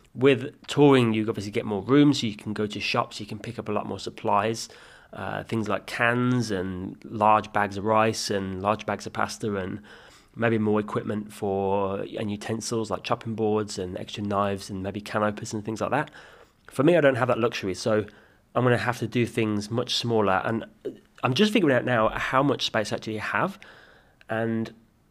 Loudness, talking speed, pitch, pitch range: -26 LUFS, 205 wpm, 110 Hz, 105-115 Hz